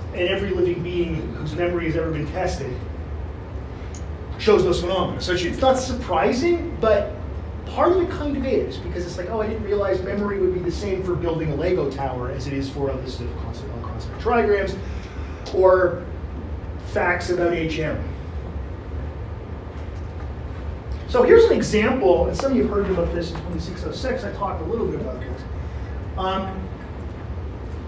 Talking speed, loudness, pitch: 160 wpm, -23 LUFS, 130 Hz